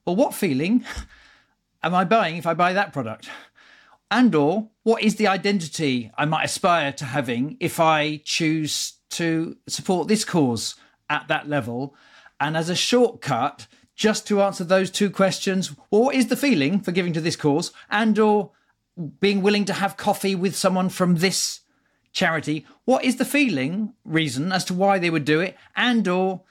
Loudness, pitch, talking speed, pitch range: -22 LUFS, 185 Hz, 180 wpm, 155-210 Hz